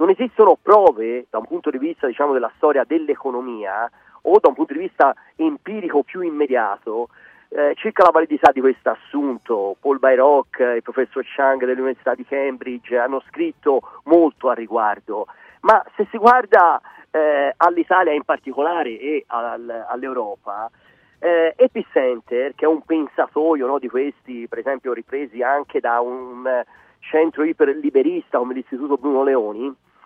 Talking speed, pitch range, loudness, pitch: 140 wpm, 125-195 Hz, -19 LUFS, 145 Hz